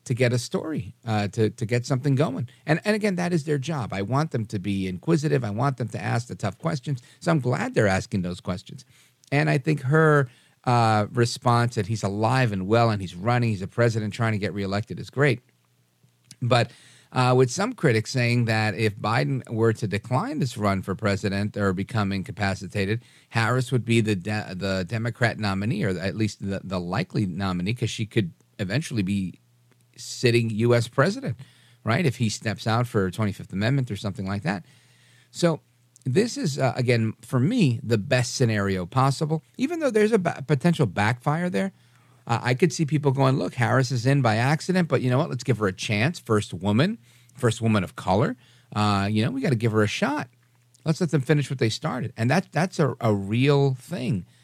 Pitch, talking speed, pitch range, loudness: 120 Hz, 205 wpm, 105-140 Hz, -24 LUFS